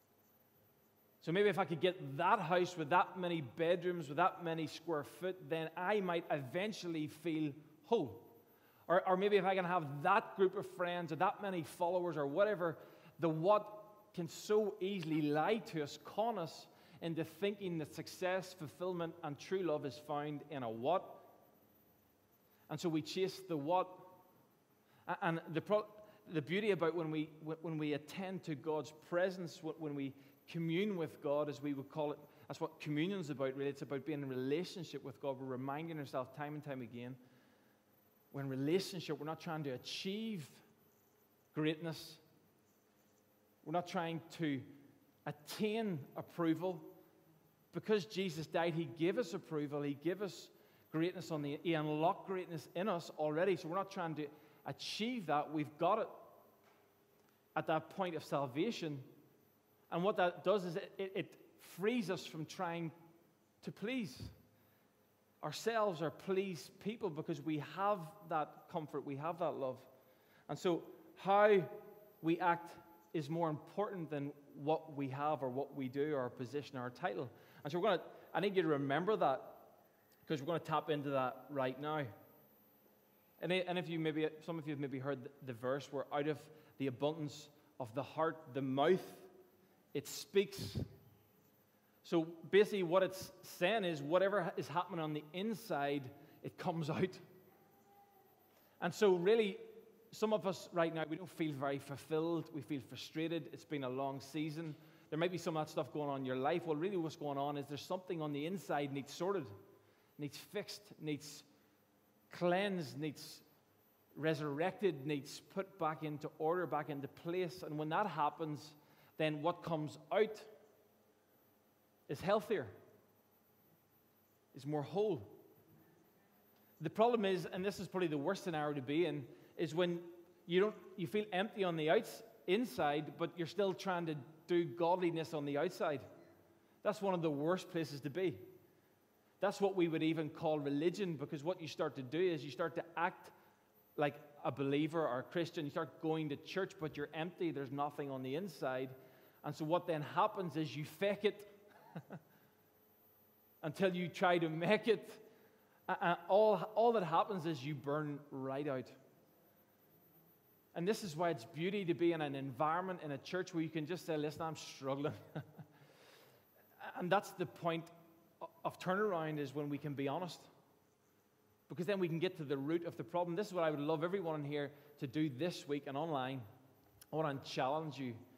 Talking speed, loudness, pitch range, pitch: 170 wpm, -40 LUFS, 145-180 Hz, 160 Hz